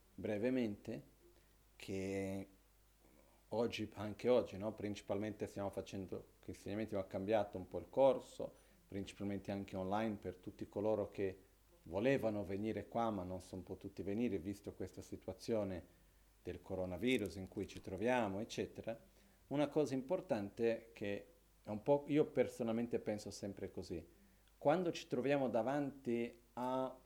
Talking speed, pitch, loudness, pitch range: 130 wpm, 100 Hz, -41 LUFS, 95-115 Hz